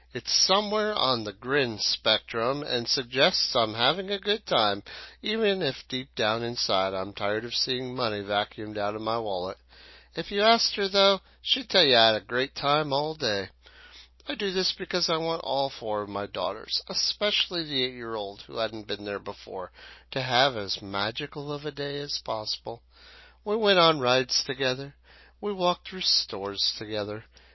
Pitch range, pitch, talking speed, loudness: 110-180 Hz, 130 Hz, 175 wpm, -26 LUFS